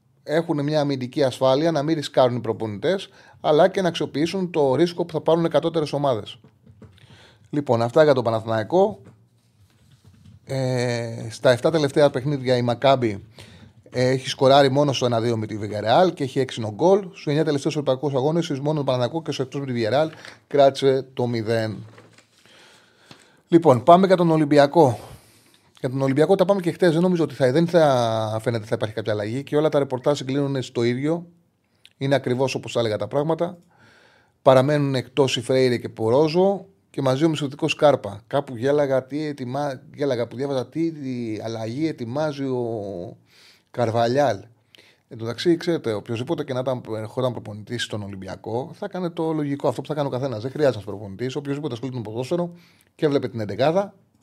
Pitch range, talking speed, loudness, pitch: 115-150 Hz, 175 wpm, -22 LUFS, 135 Hz